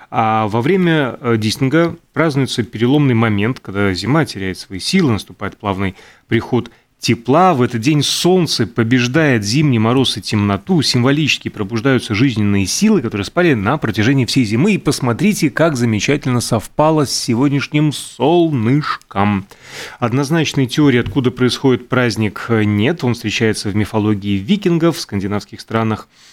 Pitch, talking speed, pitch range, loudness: 120 Hz, 130 wpm, 110-150 Hz, -15 LUFS